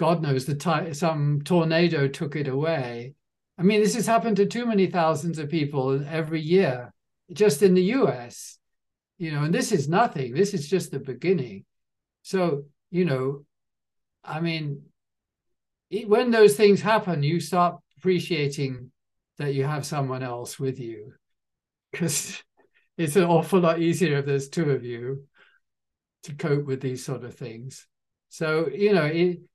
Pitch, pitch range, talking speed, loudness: 160 Hz, 135-180 Hz, 160 wpm, -24 LUFS